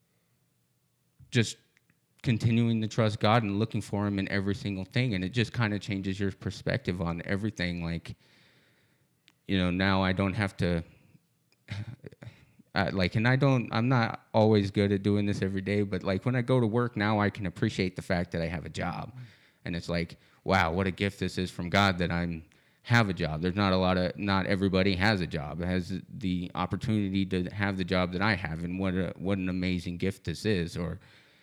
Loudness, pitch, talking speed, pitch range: -29 LUFS, 95 Hz, 210 wpm, 90-110 Hz